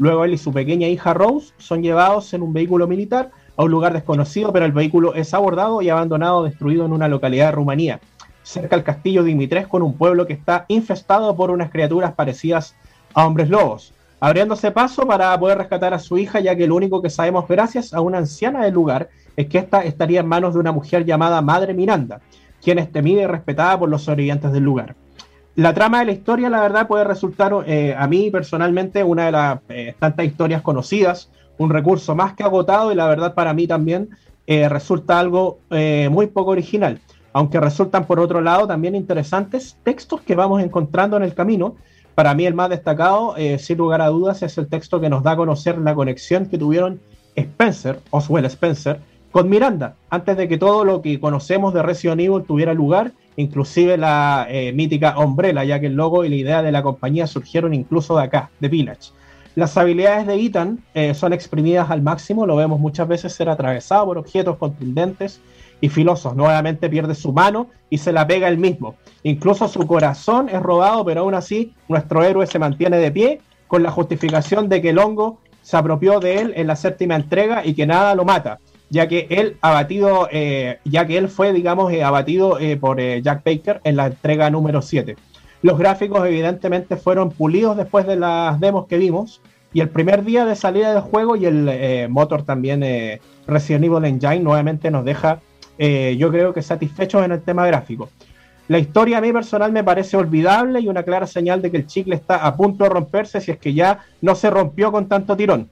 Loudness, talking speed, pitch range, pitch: -17 LUFS, 205 wpm, 150-190 Hz, 170 Hz